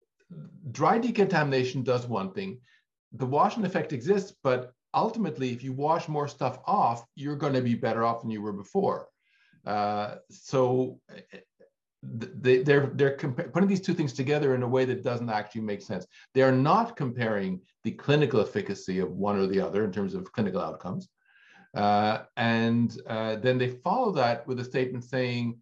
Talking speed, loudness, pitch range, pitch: 175 wpm, -28 LUFS, 115-160 Hz, 130 Hz